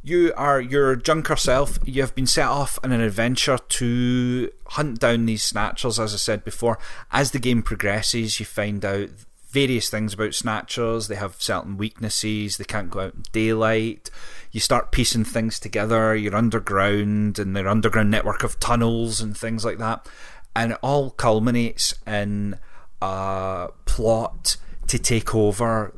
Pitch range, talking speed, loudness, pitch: 105-120 Hz, 160 wpm, -22 LUFS, 110 Hz